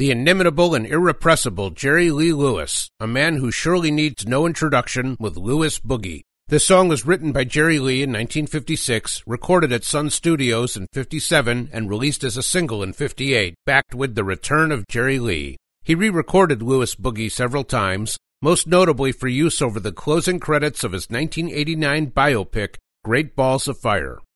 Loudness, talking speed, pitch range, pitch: -19 LUFS, 165 wpm, 115-155 Hz, 135 Hz